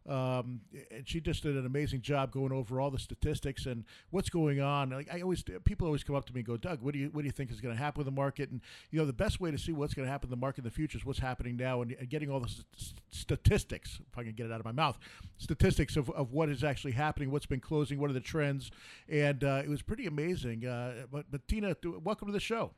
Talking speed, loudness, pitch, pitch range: 285 wpm, -35 LUFS, 140 Hz, 125-150 Hz